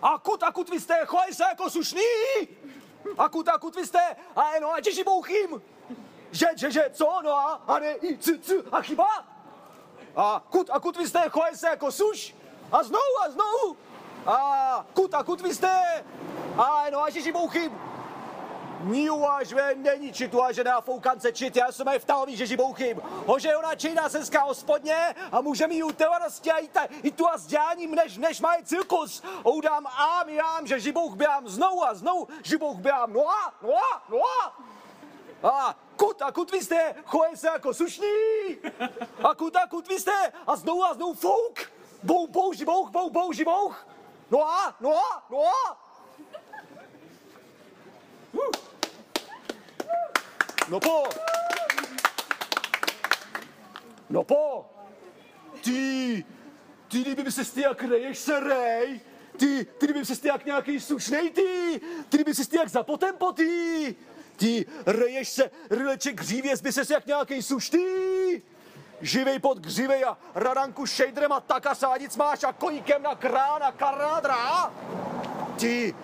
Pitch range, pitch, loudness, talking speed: 270-345 Hz, 305 Hz, -26 LUFS, 155 wpm